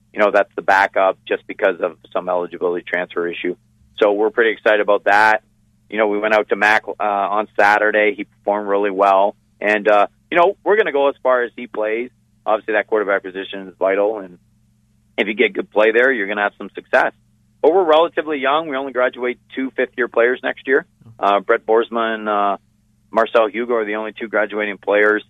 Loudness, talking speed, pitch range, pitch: -17 LUFS, 215 wpm, 100-115 Hz, 110 Hz